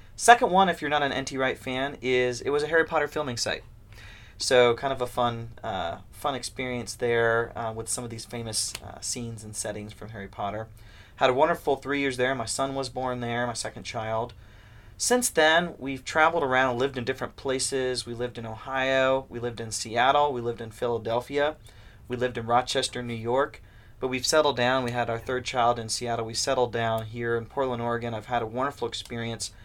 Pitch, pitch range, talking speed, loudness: 120 Hz, 115-130 Hz, 210 wpm, -27 LUFS